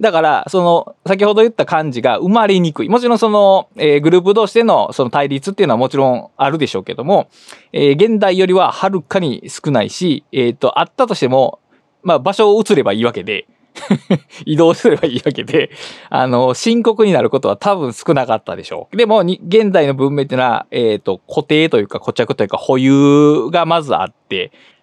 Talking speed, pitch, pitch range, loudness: 400 characters per minute, 175 Hz, 140-210 Hz, -14 LUFS